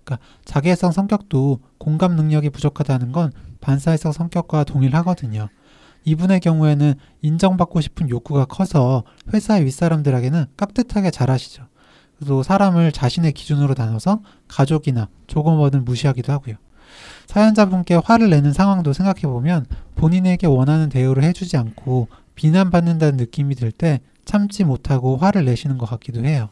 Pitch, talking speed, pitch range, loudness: 150 Hz, 360 characters per minute, 130-175 Hz, -18 LUFS